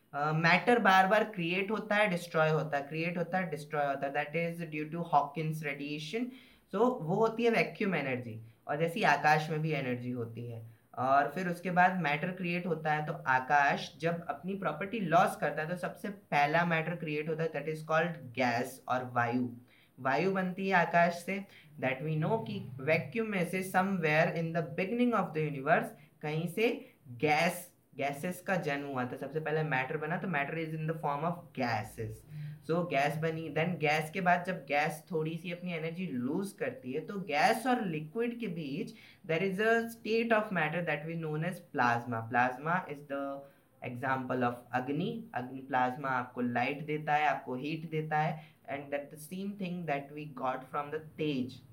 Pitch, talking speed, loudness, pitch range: 155 Hz, 190 wpm, -32 LUFS, 140-180 Hz